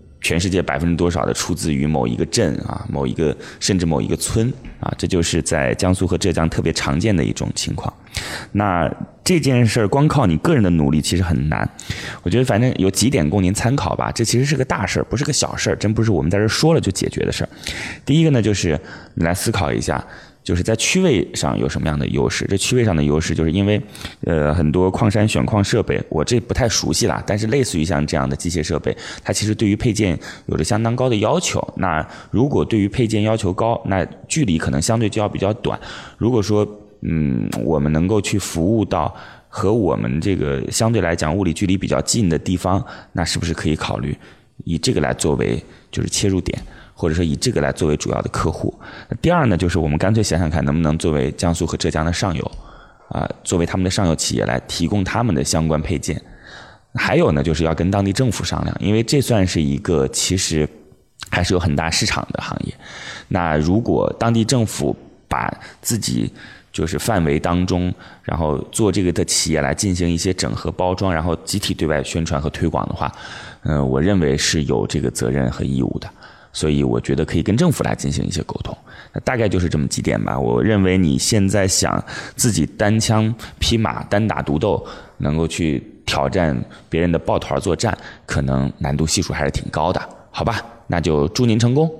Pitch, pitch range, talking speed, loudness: 90 Hz, 80-105 Hz, 315 characters per minute, -19 LUFS